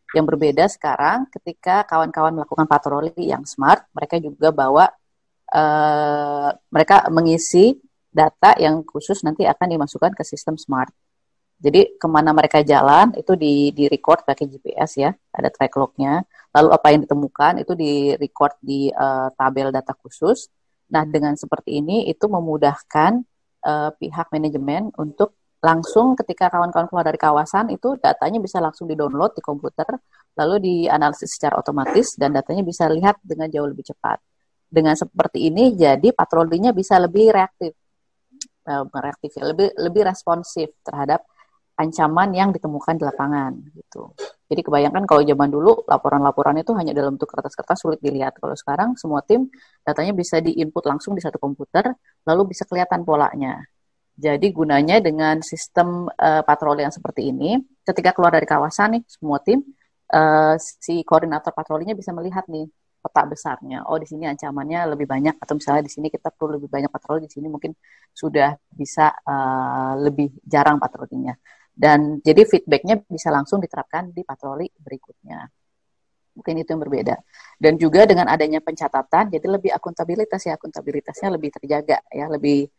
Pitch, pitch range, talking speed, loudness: 155 Hz, 145-180 Hz, 150 wpm, -19 LUFS